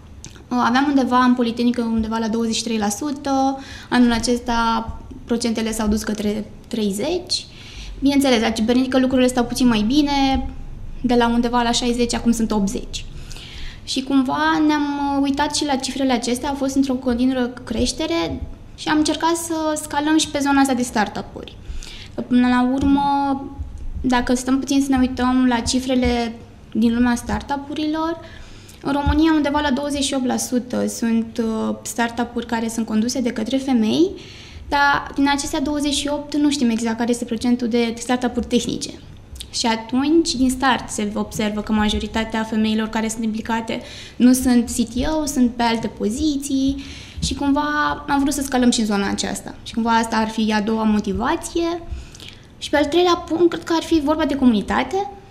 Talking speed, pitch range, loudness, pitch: 155 wpm, 230-285 Hz, -20 LUFS, 250 Hz